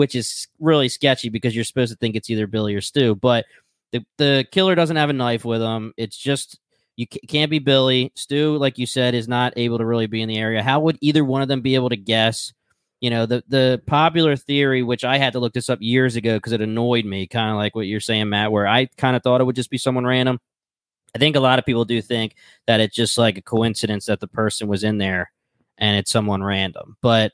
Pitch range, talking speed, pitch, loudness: 110-130 Hz, 255 wpm, 120 Hz, -20 LUFS